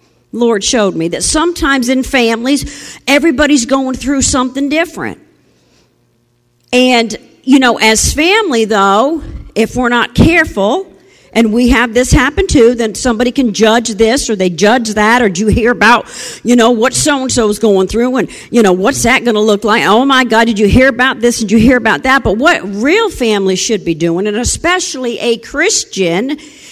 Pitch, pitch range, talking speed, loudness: 240 Hz, 215-270 Hz, 185 wpm, -10 LUFS